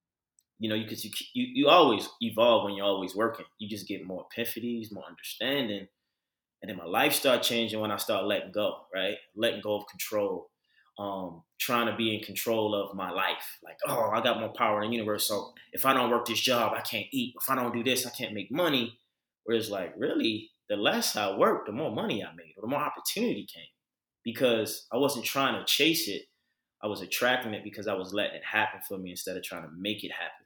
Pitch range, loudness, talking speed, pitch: 100-120 Hz, -29 LUFS, 230 wpm, 110 Hz